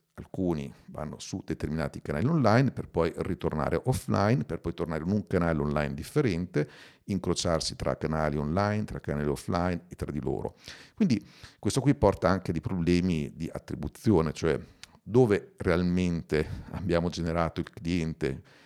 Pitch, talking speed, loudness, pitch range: 85 Hz, 150 wpm, -29 LUFS, 80-95 Hz